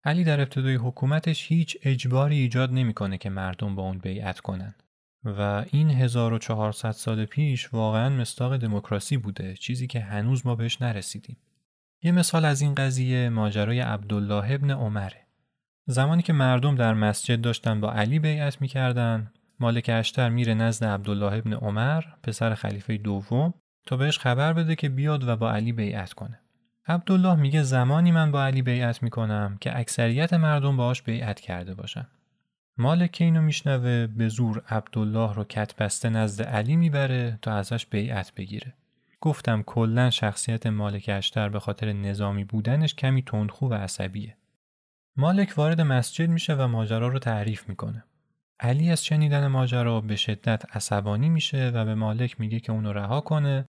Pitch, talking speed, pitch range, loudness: 120 Hz, 155 wpm, 105-140 Hz, -25 LUFS